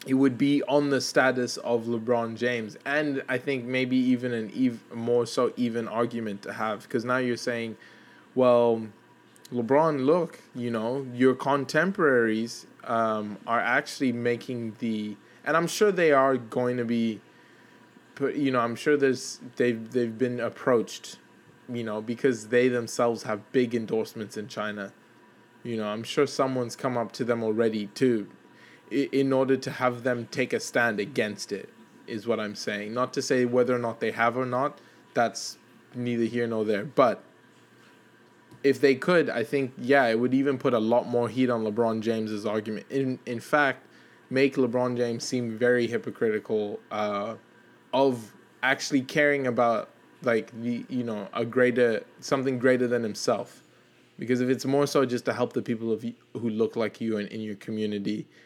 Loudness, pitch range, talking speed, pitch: -27 LUFS, 115-130 Hz, 170 wpm, 120 Hz